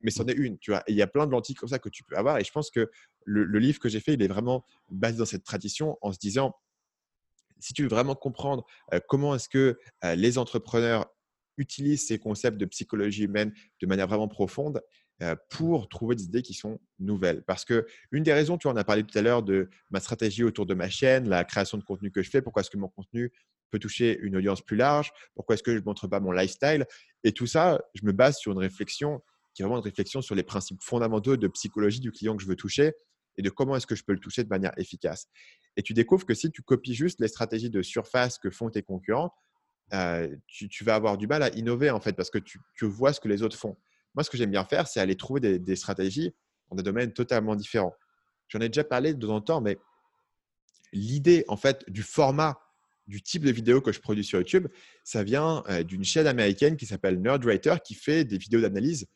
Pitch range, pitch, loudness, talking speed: 100-135 Hz, 110 Hz, -28 LUFS, 245 wpm